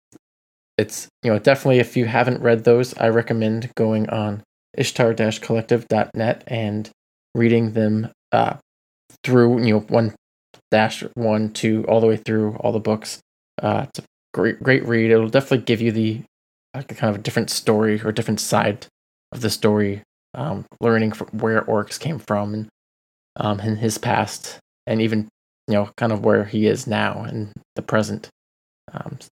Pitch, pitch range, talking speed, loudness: 110 Hz, 105-115 Hz, 165 wpm, -20 LUFS